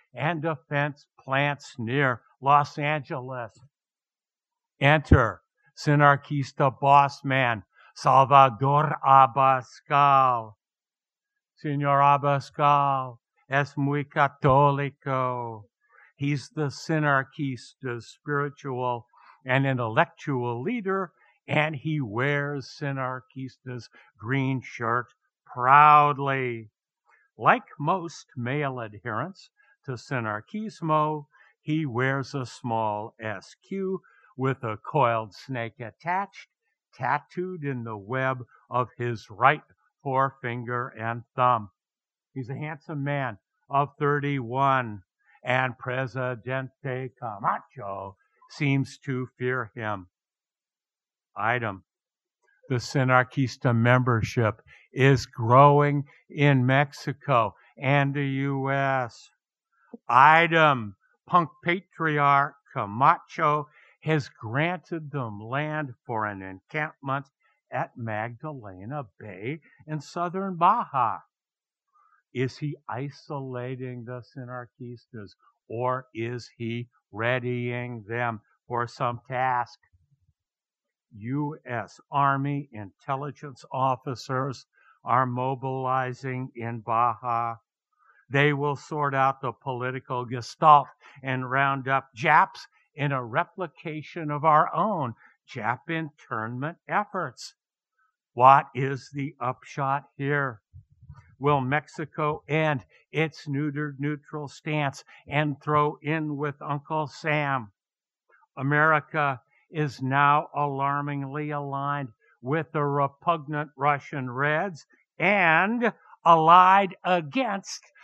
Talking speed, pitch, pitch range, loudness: 85 wpm, 135 Hz, 125-150 Hz, -25 LUFS